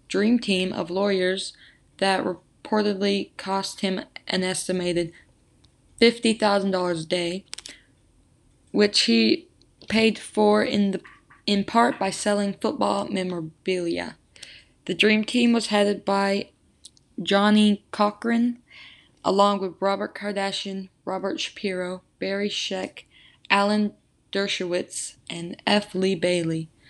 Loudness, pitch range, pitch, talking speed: -24 LUFS, 185-210 Hz, 195 Hz, 105 wpm